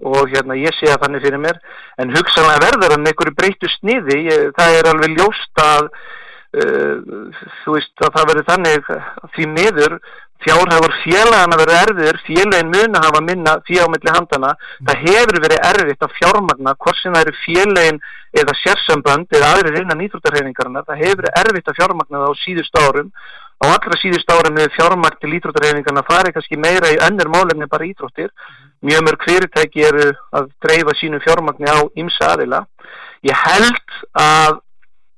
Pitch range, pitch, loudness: 150-175 Hz, 155 Hz, -13 LUFS